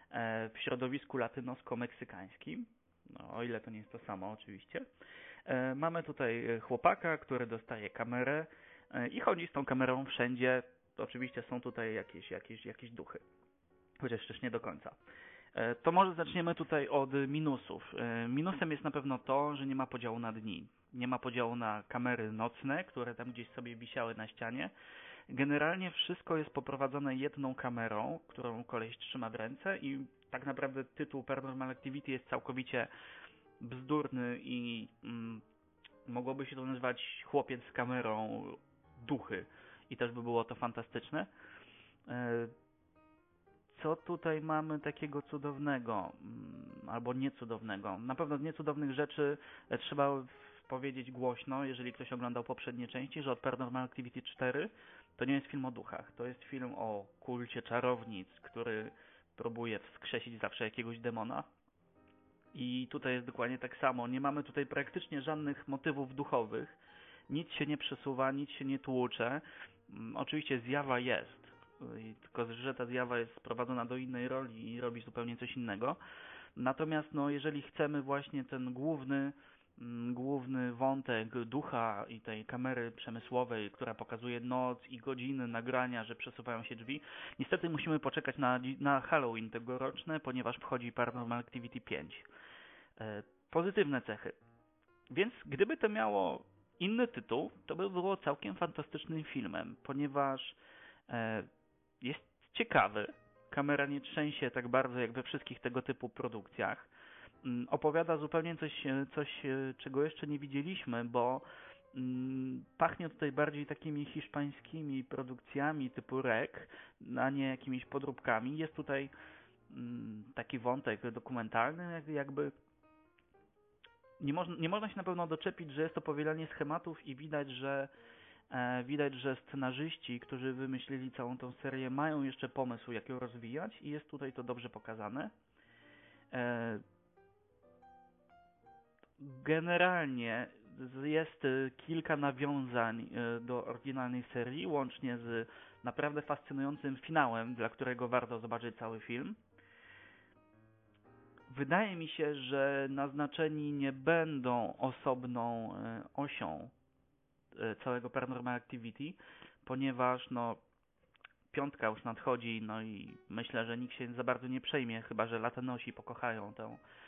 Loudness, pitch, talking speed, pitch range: -39 LUFS, 130 Hz, 130 wpm, 120-145 Hz